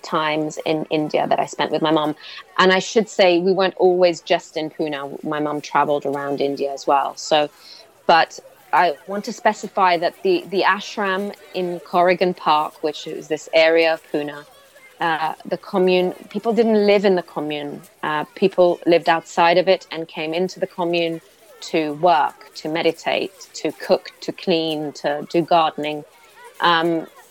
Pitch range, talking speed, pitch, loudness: 155-185 Hz, 170 wpm, 170 Hz, -20 LUFS